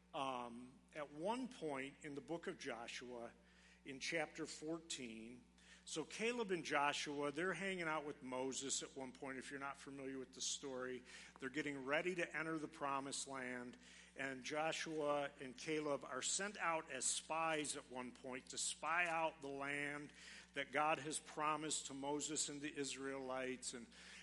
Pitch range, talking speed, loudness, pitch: 130-155 Hz, 165 wpm, -45 LUFS, 145 Hz